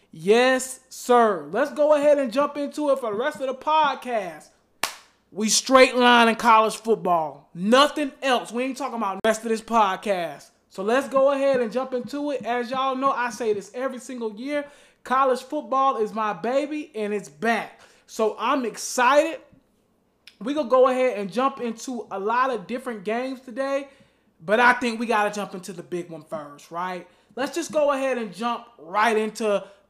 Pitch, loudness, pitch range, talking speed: 245 Hz, -23 LUFS, 215-270 Hz, 190 wpm